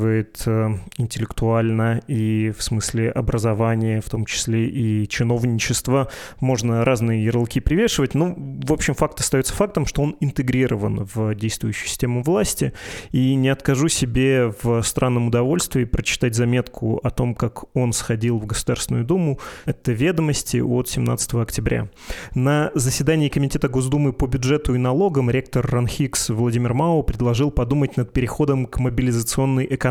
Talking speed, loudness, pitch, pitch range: 135 wpm, -21 LUFS, 125 Hz, 115-135 Hz